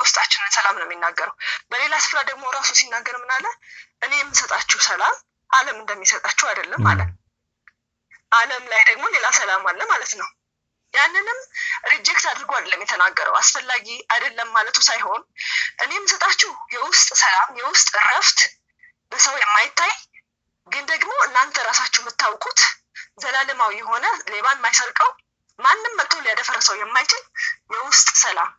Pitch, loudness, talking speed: 270 Hz, -17 LUFS, 120 wpm